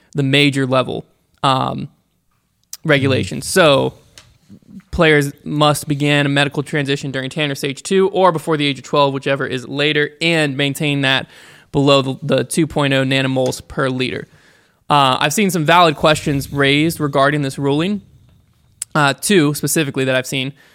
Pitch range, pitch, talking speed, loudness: 135-155 Hz, 145 Hz, 150 wpm, -16 LUFS